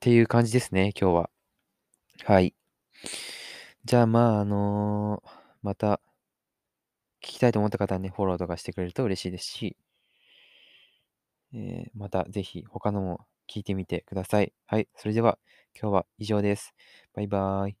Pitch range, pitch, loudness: 95-115 Hz, 105 Hz, -27 LUFS